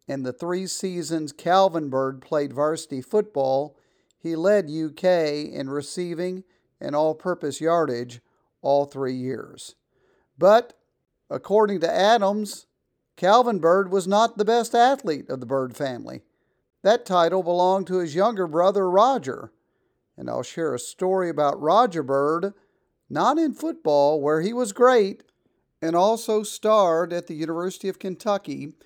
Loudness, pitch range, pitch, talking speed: -23 LUFS, 150-195 Hz, 175 Hz, 140 wpm